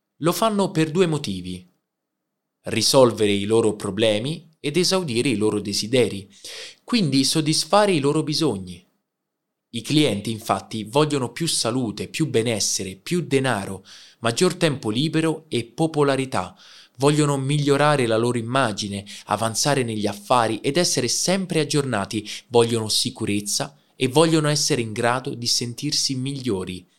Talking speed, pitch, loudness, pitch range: 125 wpm, 130 Hz, -21 LUFS, 105-150 Hz